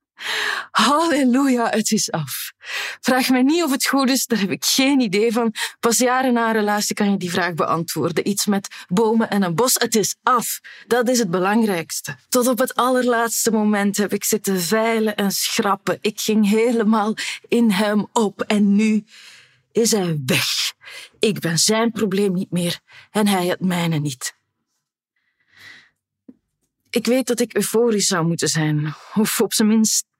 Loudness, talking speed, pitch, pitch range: -19 LUFS, 170 wpm, 215 Hz, 195-235 Hz